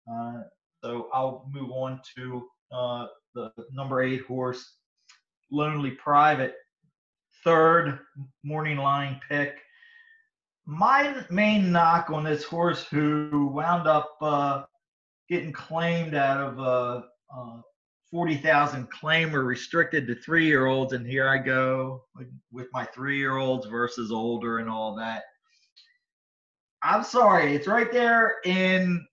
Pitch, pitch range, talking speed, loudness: 145 Hz, 130-170 Hz, 125 wpm, -25 LUFS